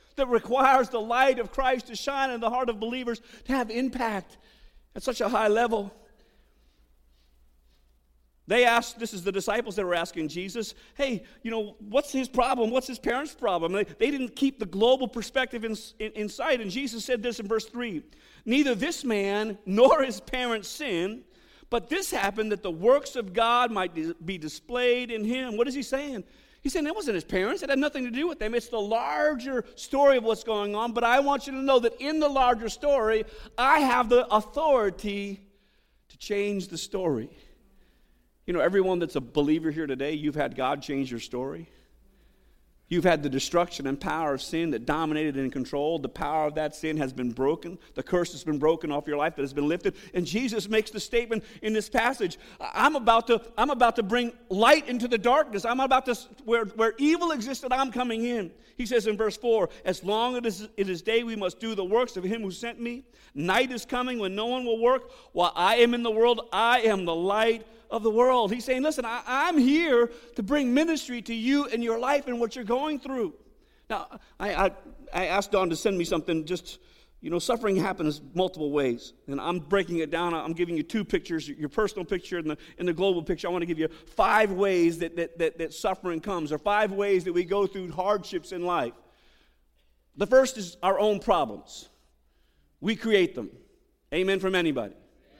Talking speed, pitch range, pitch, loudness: 210 wpm, 175-245 Hz, 220 Hz, -27 LUFS